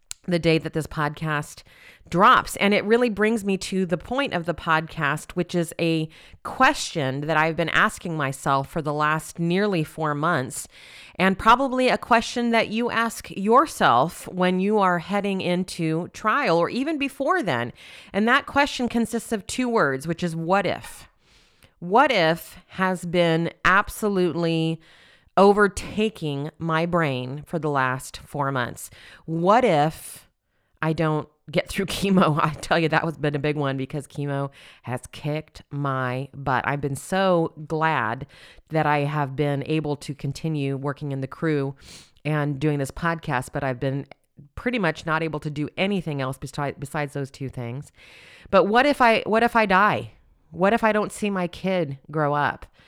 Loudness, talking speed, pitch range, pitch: -23 LUFS, 165 wpm, 145-190 Hz, 160 Hz